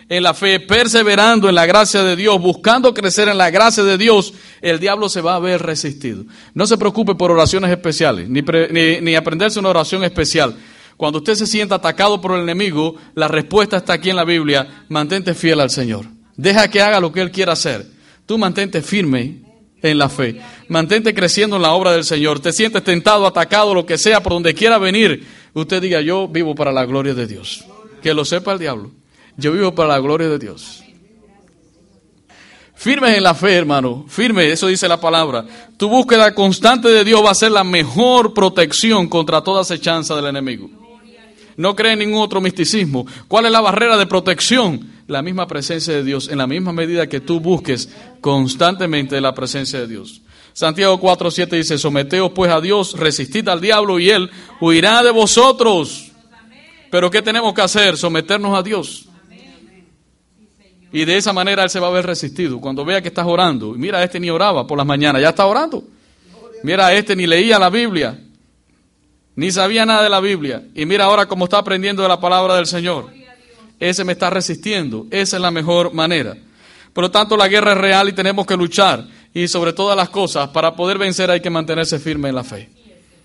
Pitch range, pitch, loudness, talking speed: 160-205 Hz, 180 Hz, -14 LUFS, 195 wpm